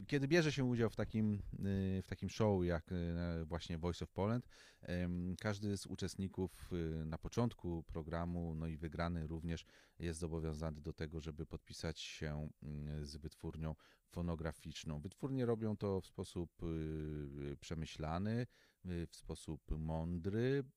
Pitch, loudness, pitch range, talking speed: 85 Hz, -43 LUFS, 80-95 Hz, 125 wpm